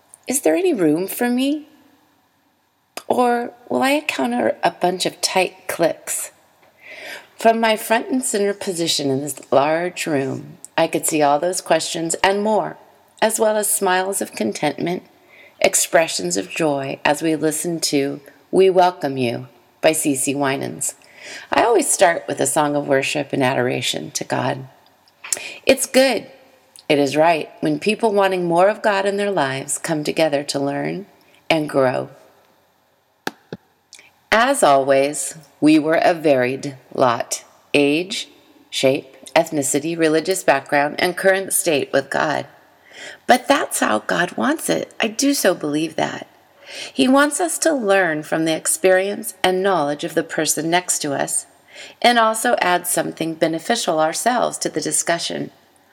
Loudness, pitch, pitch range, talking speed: -19 LUFS, 170 Hz, 145-210 Hz, 145 wpm